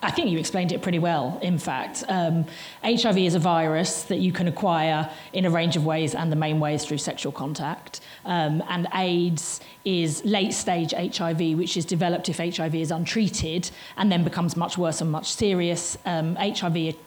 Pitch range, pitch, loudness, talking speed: 160-180 Hz, 170 Hz, -25 LUFS, 190 wpm